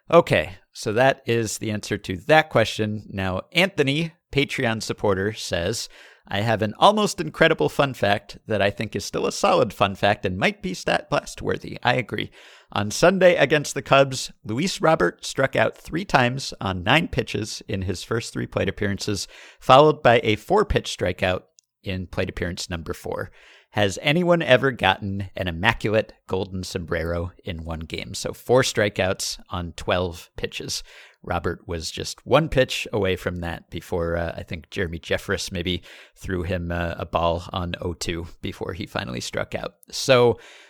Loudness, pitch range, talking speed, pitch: -23 LUFS, 95-135 Hz, 170 wpm, 105 Hz